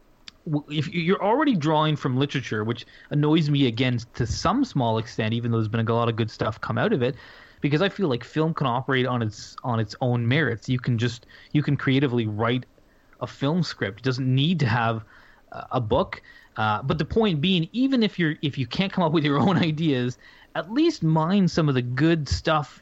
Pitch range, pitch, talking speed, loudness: 120-165 Hz, 140 Hz, 215 wpm, -24 LUFS